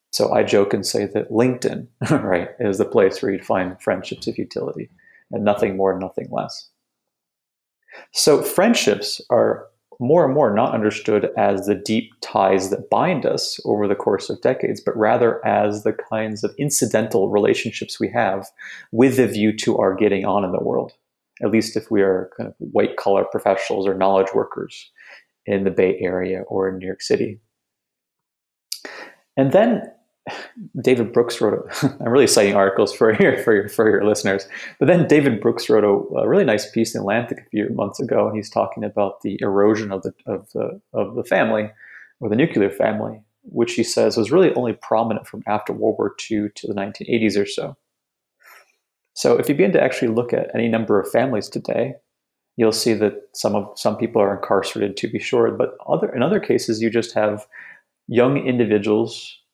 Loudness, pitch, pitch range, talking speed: -19 LUFS, 110 Hz, 100-115 Hz, 190 wpm